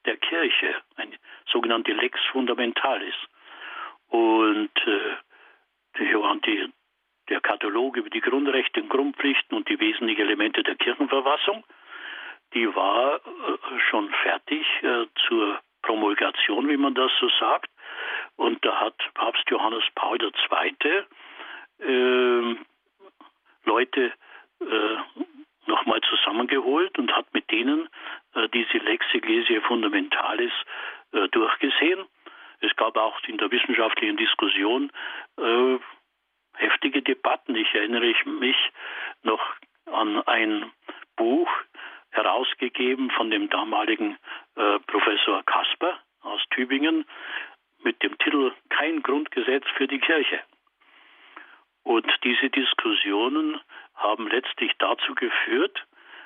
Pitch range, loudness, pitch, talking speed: 250-360 Hz, -24 LUFS, 330 Hz, 105 wpm